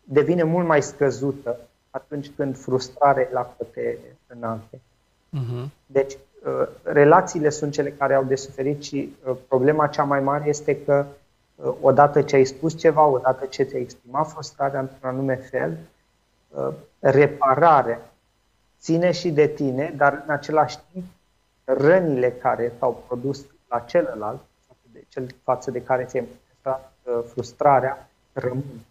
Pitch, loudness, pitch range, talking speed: 140 Hz, -22 LUFS, 130-150 Hz, 135 wpm